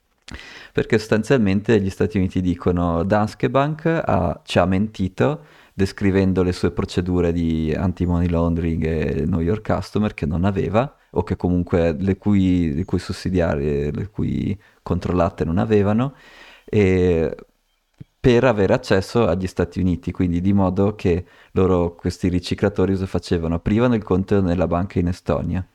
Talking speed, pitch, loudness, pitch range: 145 wpm, 90 Hz, -20 LUFS, 85-100 Hz